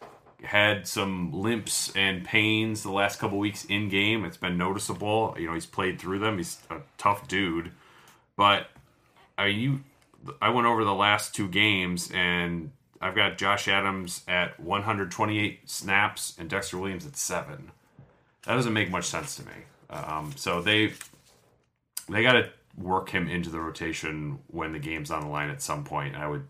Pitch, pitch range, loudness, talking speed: 100 Hz, 85-105 Hz, -27 LUFS, 175 wpm